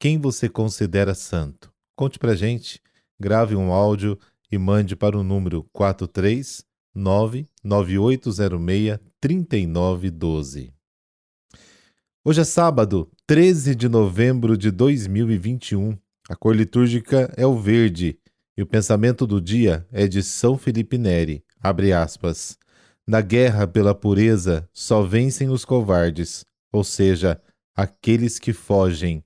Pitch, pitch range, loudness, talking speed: 105 Hz, 95-120 Hz, -20 LUFS, 115 wpm